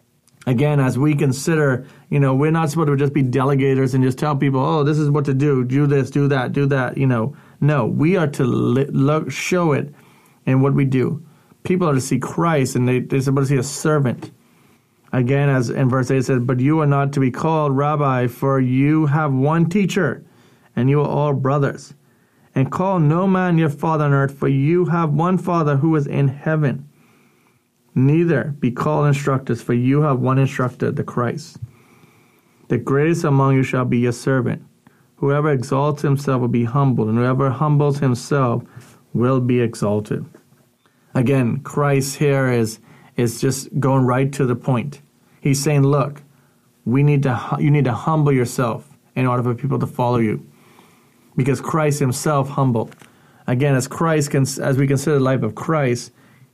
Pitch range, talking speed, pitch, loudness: 130-150 Hz, 185 wpm, 140 Hz, -18 LUFS